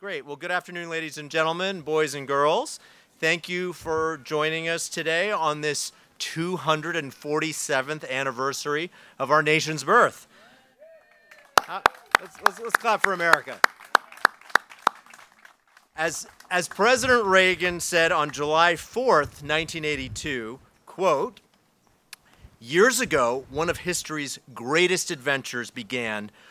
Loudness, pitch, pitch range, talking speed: -24 LUFS, 160 Hz, 145-175 Hz, 110 wpm